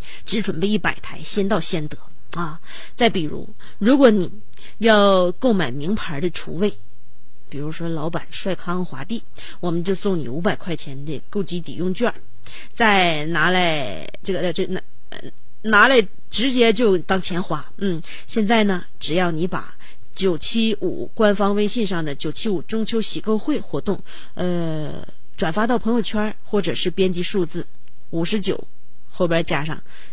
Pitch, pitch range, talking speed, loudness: 180 Hz, 160-210 Hz, 225 characters per minute, -21 LUFS